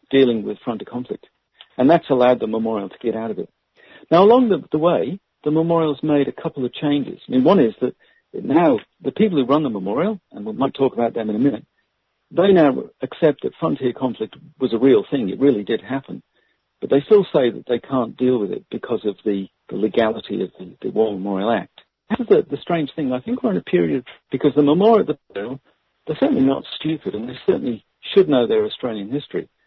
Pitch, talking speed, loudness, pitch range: 140 Hz, 220 wpm, -19 LUFS, 120-175 Hz